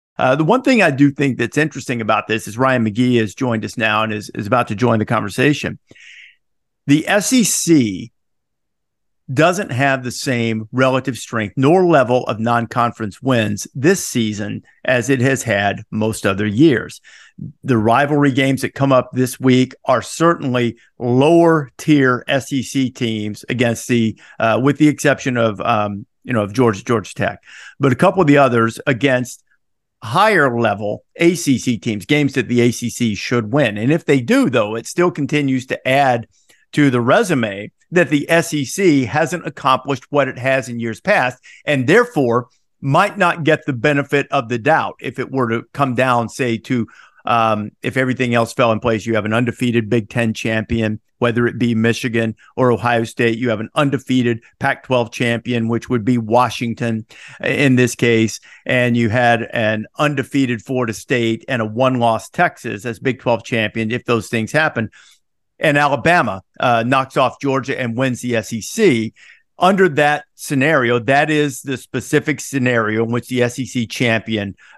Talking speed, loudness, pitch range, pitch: 170 wpm, -17 LUFS, 115-140 Hz, 125 Hz